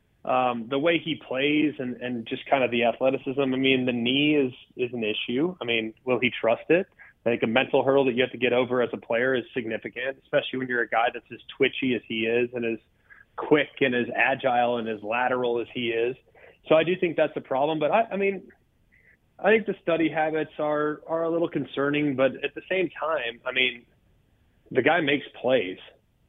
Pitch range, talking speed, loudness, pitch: 120-150 Hz, 220 wpm, -25 LUFS, 130 Hz